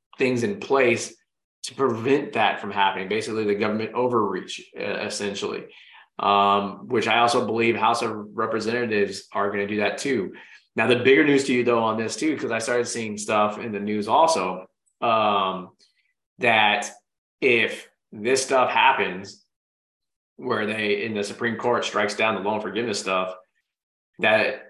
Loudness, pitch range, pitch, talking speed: -23 LUFS, 100-120 Hz, 110 Hz, 160 wpm